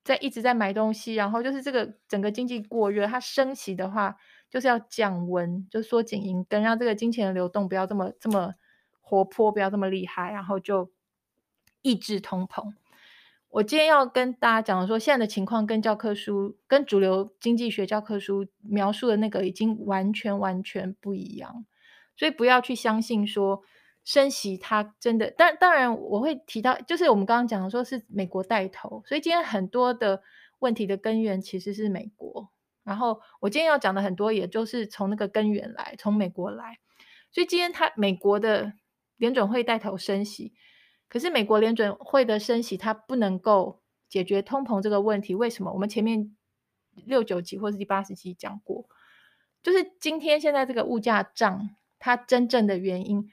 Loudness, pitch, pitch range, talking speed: -26 LUFS, 215 Hz, 200-245 Hz, 280 characters per minute